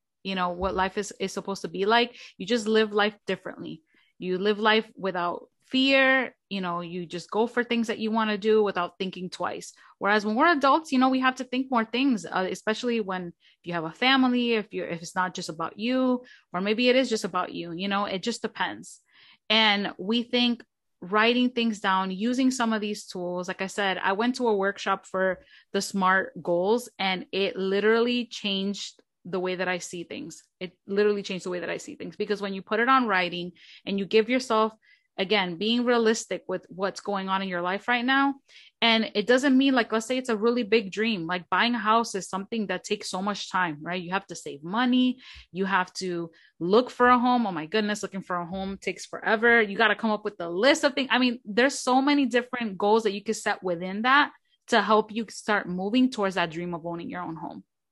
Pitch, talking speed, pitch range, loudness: 210 Hz, 230 wpm, 185-235 Hz, -26 LUFS